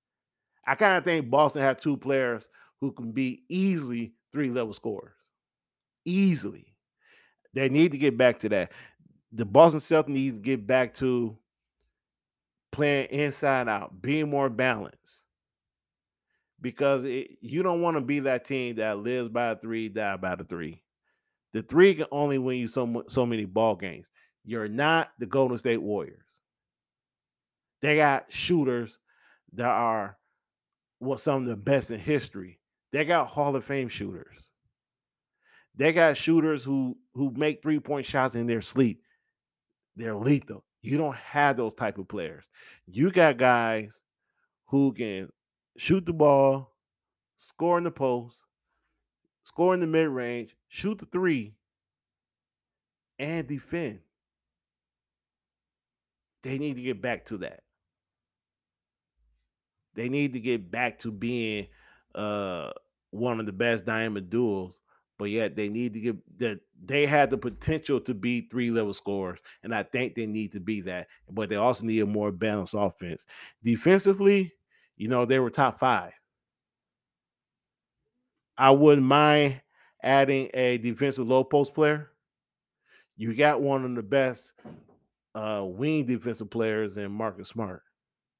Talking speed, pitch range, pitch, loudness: 145 wpm, 110-145 Hz, 125 Hz, -27 LUFS